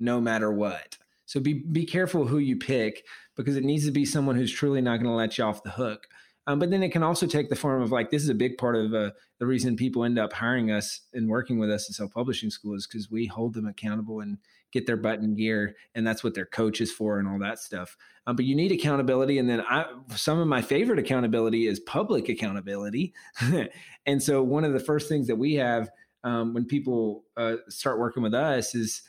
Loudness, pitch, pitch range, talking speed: -27 LUFS, 120 Hz, 110-140 Hz, 240 wpm